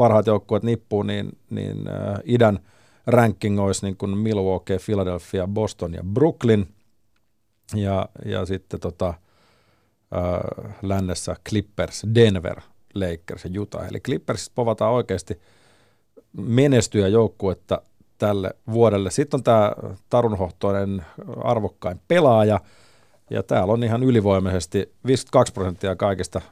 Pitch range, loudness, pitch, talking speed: 95-115 Hz, -22 LUFS, 105 Hz, 110 wpm